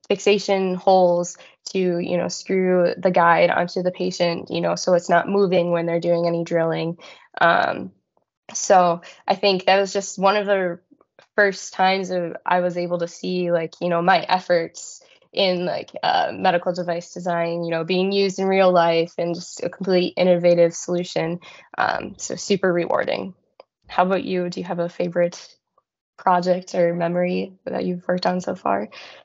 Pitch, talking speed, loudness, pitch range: 180 Hz, 175 wpm, -21 LUFS, 170-190 Hz